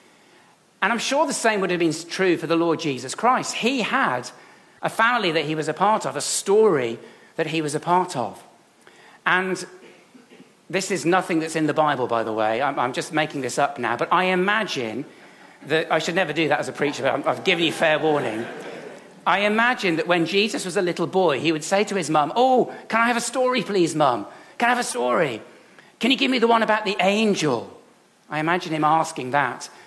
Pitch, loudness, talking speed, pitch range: 175 Hz, -22 LUFS, 215 wpm, 155-215 Hz